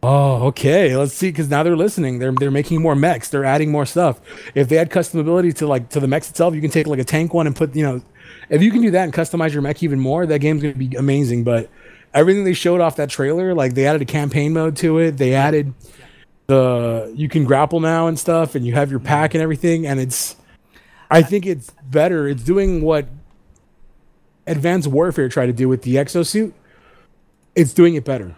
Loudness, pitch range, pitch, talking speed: -17 LUFS, 135-165 Hz, 150 Hz, 225 wpm